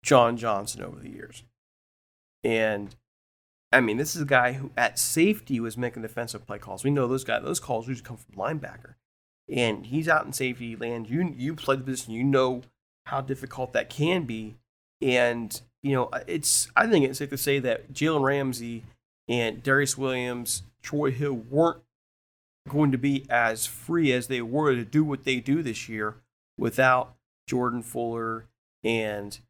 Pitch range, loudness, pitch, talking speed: 115-135 Hz, -26 LUFS, 125 Hz, 175 wpm